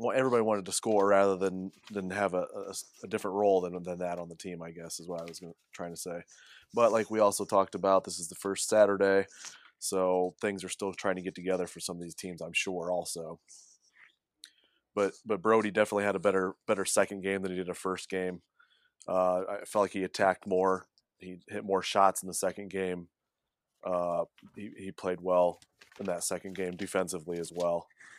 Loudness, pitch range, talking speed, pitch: -31 LUFS, 90-100 Hz, 215 wpm, 95 Hz